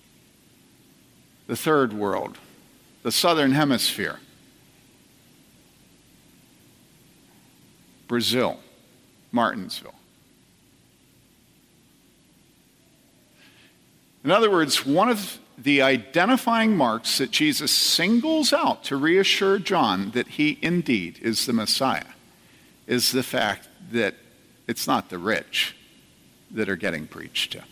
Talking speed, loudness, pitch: 90 wpm, -22 LUFS, 165 Hz